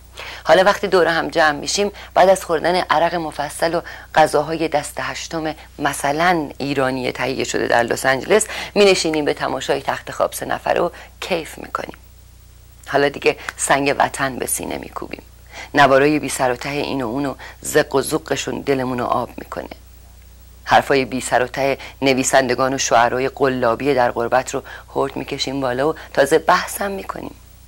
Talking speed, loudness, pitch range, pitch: 150 wpm, -18 LUFS, 125-155 Hz, 135 Hz